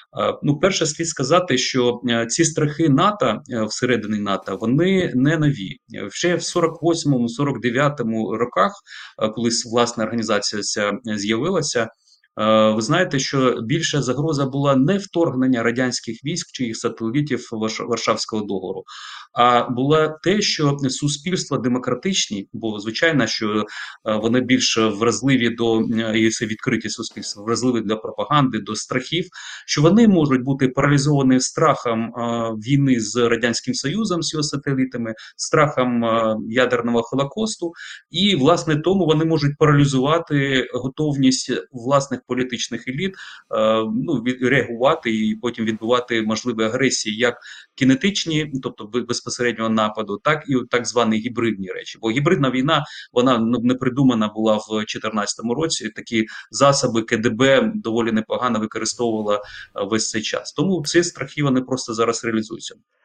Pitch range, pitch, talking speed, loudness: 115-145 Hz, 125 Hz, 125 wpm, -20 LUFS